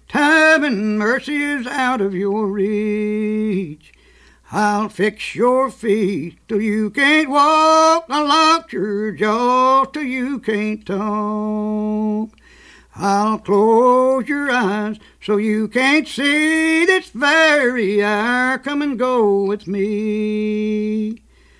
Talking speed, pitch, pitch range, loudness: 110 wpm, 215 Hz, 210-275 Hz, -17 LUFS